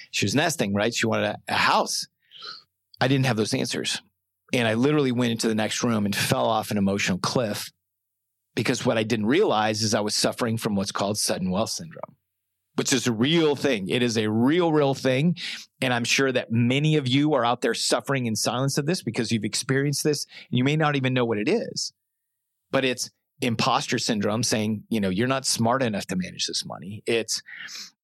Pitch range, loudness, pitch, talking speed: 110-135 Hz, -24 LUFS, 120 Hz, 210 wpm